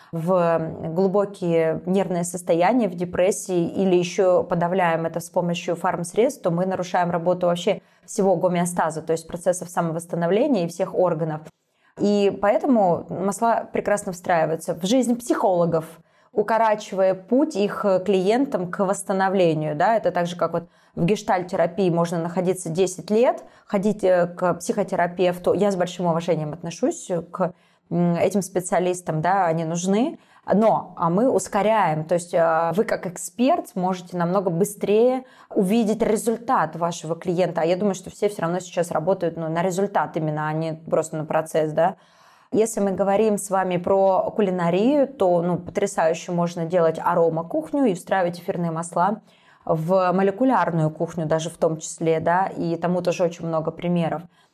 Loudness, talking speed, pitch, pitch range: -22 LUFS, 145 wpm, 180 Hz, 170-200 Hz